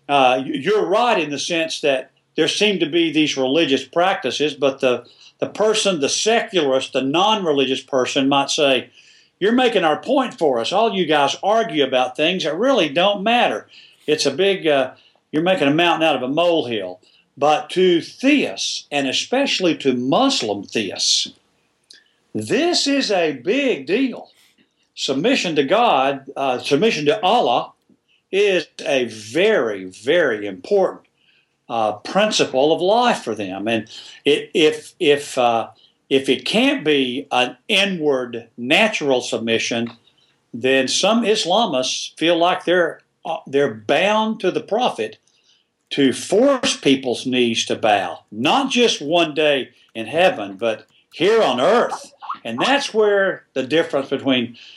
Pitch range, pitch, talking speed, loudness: 130-200 Hz, 150 Hz, 145 wpm, -18 LUFS